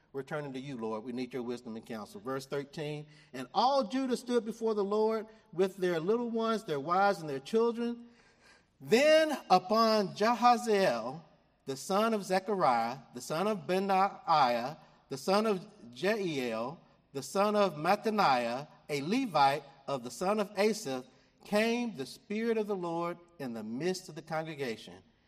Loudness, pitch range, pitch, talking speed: -31 LUFS, 140-220 Hz, 190 Hz, 160 wpm